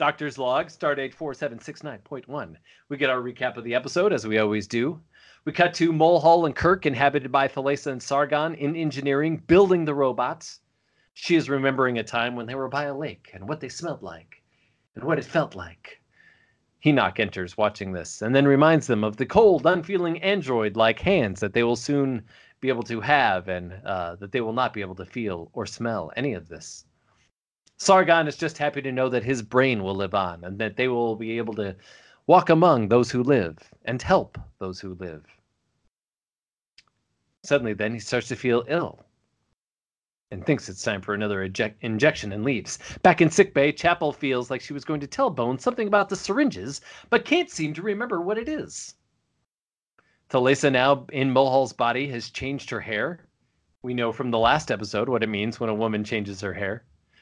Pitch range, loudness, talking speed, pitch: 110-150 Hz, -24 LUFS, 195 wpm, 130 Hz